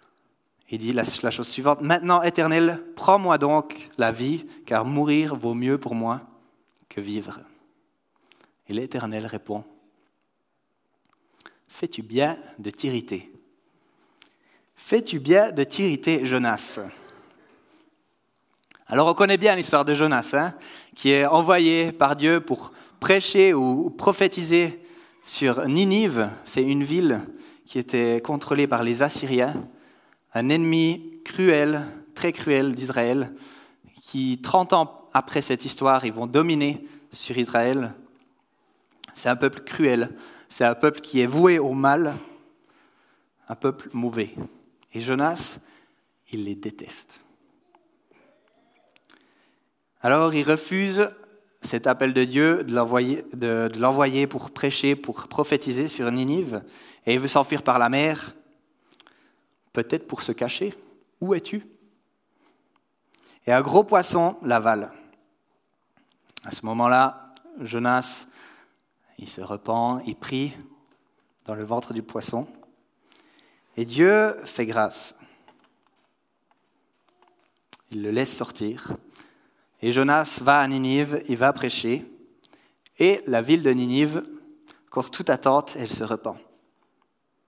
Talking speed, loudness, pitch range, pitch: 115 wpm, -23 LUFS, 125-190 Hz, 145 Hz